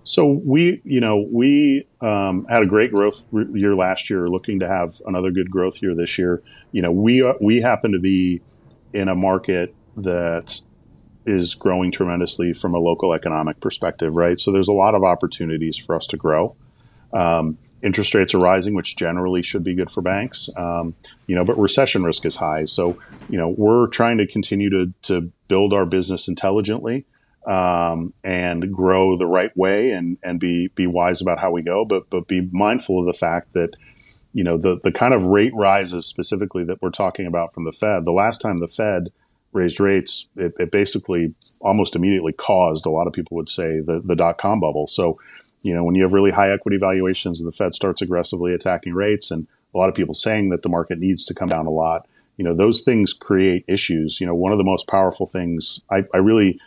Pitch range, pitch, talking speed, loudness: 85-100 Hz, 95 Hz, 210 wpm, -19 LUFS